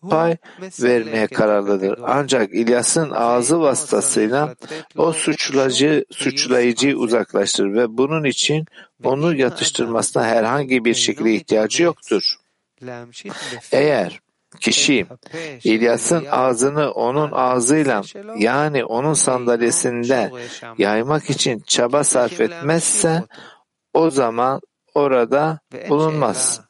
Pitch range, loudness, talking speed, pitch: 120-155 Hz, -18 LUFS, 90 wpm, 130 Hz